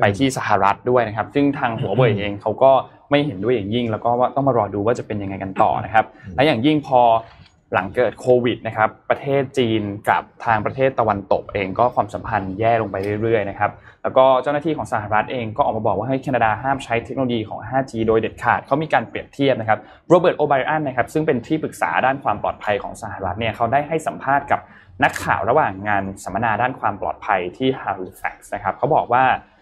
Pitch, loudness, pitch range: 115 Hz, -20 LUFS, 105-135 Hz